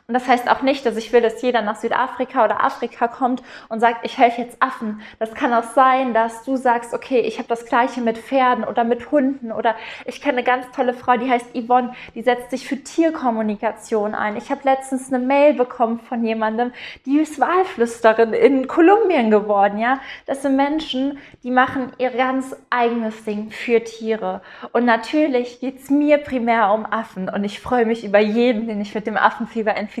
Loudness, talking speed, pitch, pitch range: -19 LUFS, 200 wpm, 240 Hz, 225-260 Hz